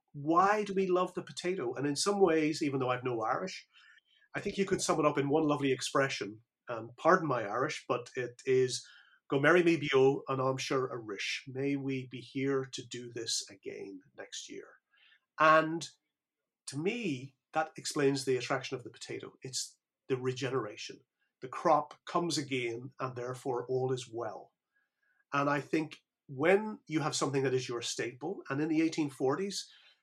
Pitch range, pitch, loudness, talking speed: 130-165 Hz, 140 Hz, -32 LUFS, 180 wpm